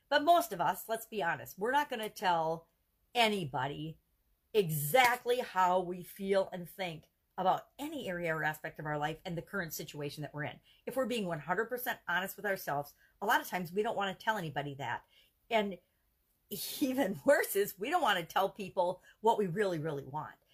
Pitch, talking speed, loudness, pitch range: 185 Hz, 195 wpm, -34 LUFS, 160-225 Hz